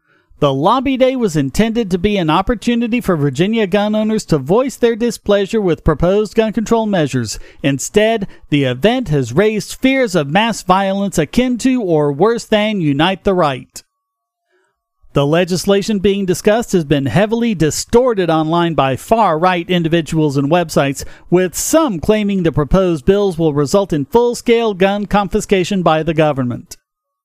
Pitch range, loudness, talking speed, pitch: 160-220 Hz, -15 LUFS, 155 wpm, 195 Hz